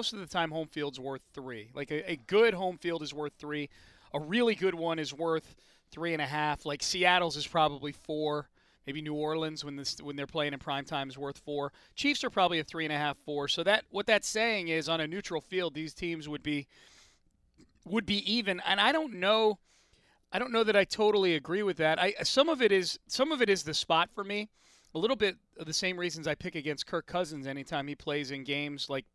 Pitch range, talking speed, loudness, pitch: 145-195 Hz, 235 wpm, -31 LUFS, 160 Hz